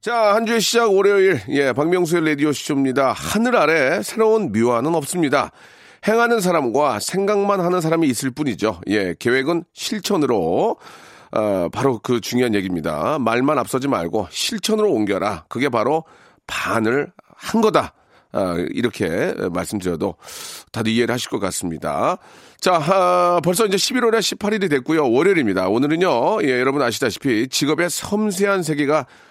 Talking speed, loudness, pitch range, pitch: 330 characters per minute, -19 LUFS, 135-210 Hz, 175 Hz